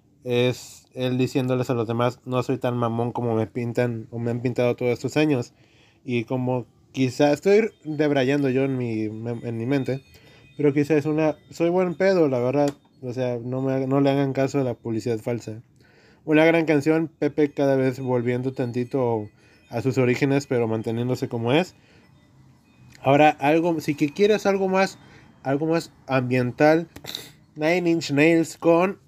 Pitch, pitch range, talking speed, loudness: 130 Hz, 120-150 Hz, 165 wpm, -23 LUFS